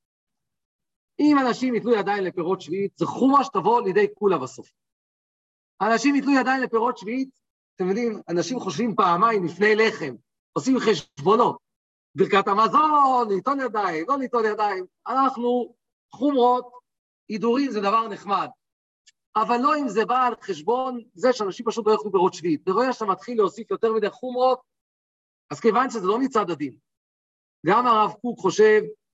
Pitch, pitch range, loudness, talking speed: 230 Hz, 205-255 Hz, -22 LUFS, 140 wpm